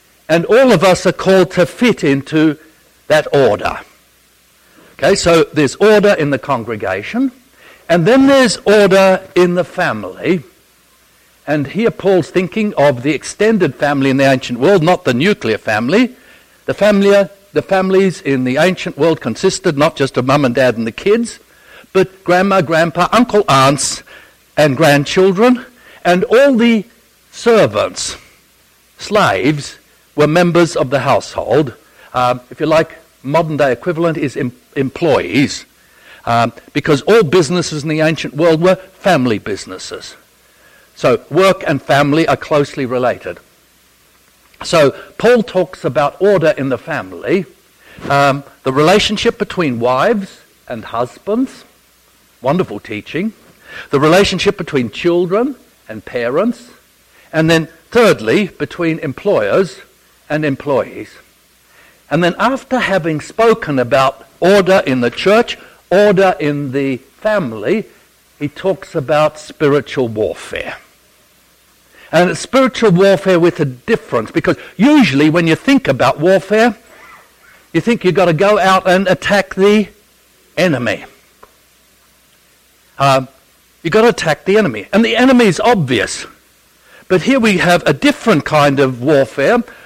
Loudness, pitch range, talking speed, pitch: -13 LUFS, 145-205 Hz, 130 wpm, 180 Hz